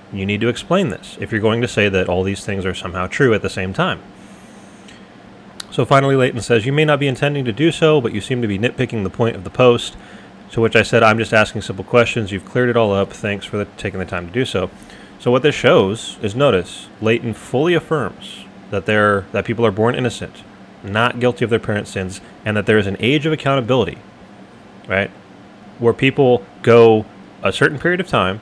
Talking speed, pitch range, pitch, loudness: 225 wpm, 100-125 Hz, 115 Hz, -17 LUFS